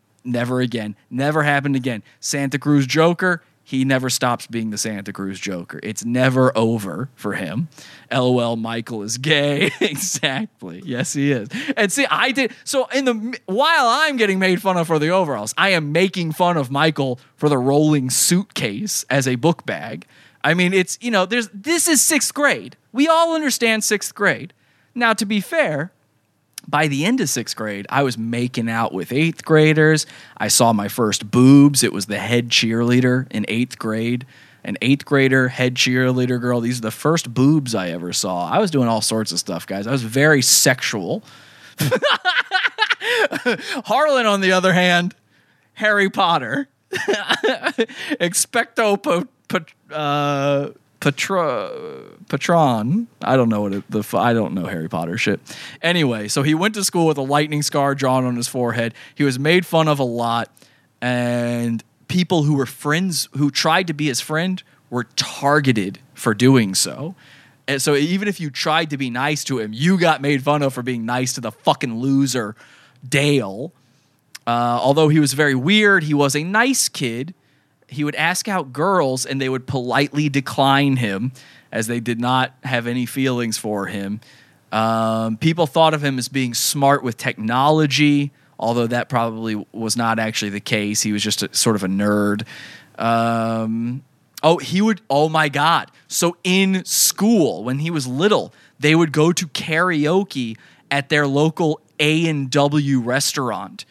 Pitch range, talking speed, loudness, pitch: 120-165 Hz, 175 wpm, -18 LUFS, 140 Hz